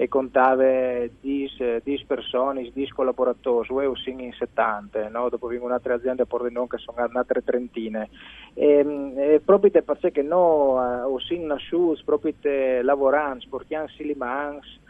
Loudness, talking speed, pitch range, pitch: -23 LUFS, 145 wpm, 125-145 Hz, 130 Hz